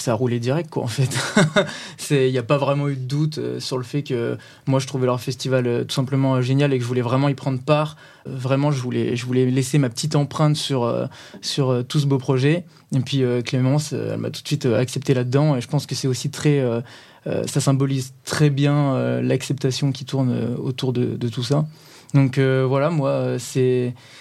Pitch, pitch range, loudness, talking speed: 135 Hz, 125-145 Hz, -21 LUFS, 240 wpm